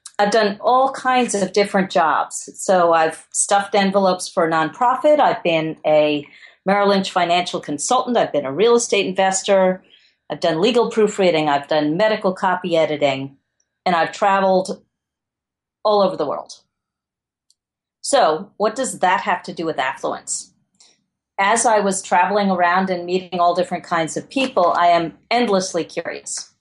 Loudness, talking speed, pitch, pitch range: -18 LUFS, 155 wpm, 185 Hz, 170-205 Hz